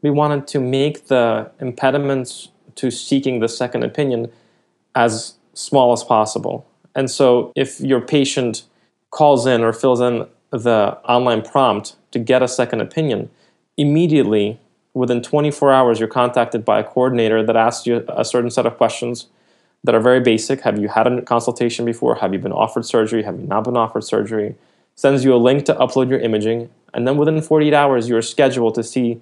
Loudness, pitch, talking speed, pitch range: -17 LUFS, 125 Hz, 180 wpm, 115-135 Hz